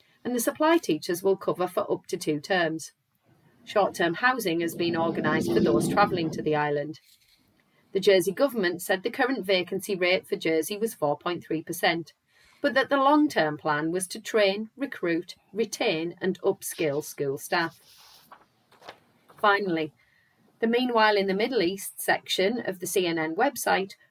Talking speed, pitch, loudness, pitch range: 155 wpm, 185 Hz, -26 LUFS, 160-215 Hz